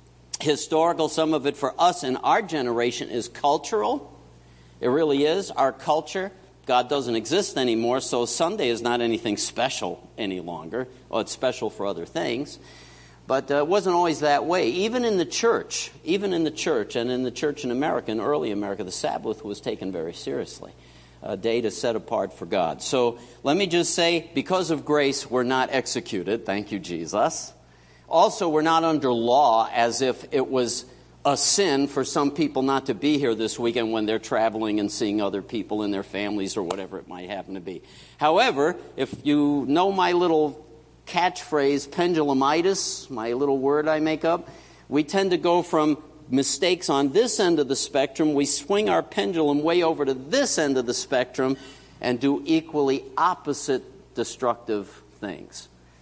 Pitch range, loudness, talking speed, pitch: 115-155 Hz, -24 LUFS, 180 wpm, 135 Hz